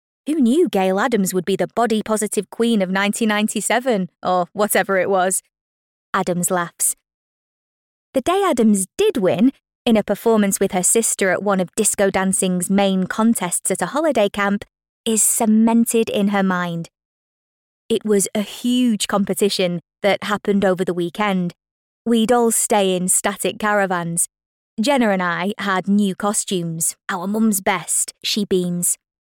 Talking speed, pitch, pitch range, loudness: 145 wpm, 200 Hz, 185-220 Hz, -18 LUFS